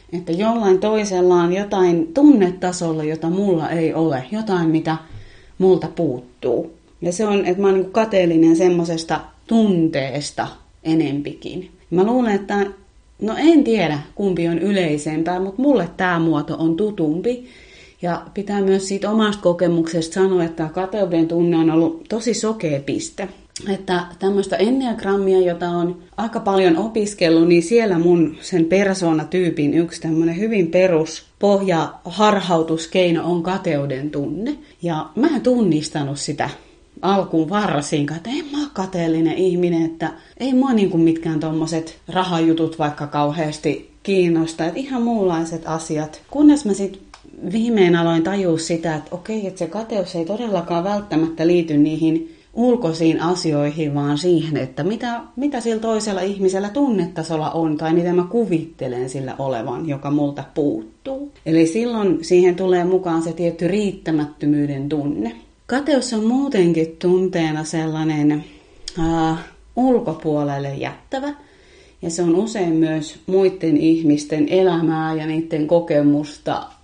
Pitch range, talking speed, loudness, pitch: 160-195 Hz, 135 wpm, -19 LUFS, 170 Hz